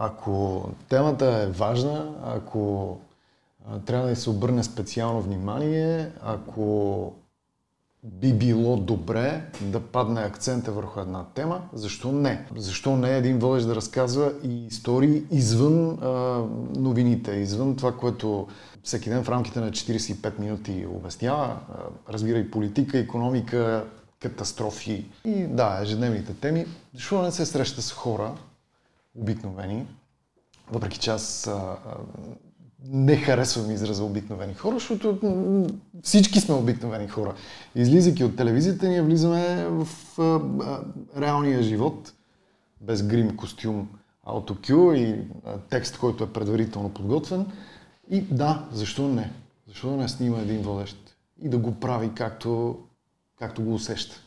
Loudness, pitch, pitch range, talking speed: -26 LUFS, 115 Hz, 105-135 Hz, 120 wpm